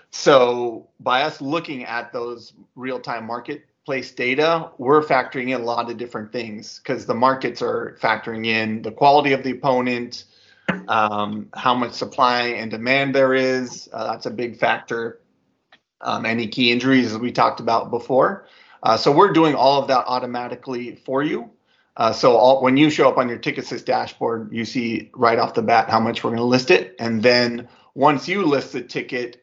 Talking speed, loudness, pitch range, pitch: 190 wpm, -20 LUFS, 115-130 Hz, 125 Hz